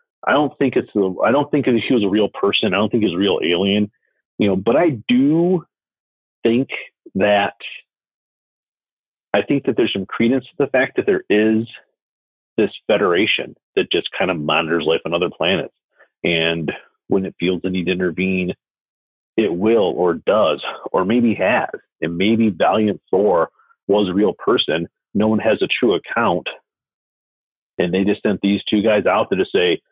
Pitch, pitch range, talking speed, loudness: 110 Hz, 95-135 Hz, 185 wpm, -18 LUFS